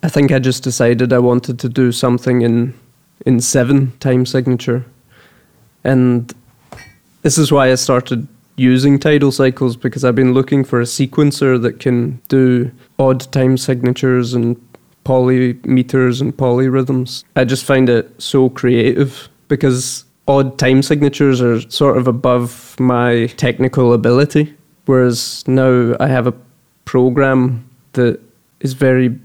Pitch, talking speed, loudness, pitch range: 130 Hz, 135 wpm, -14 LUFS, 125-135 Hz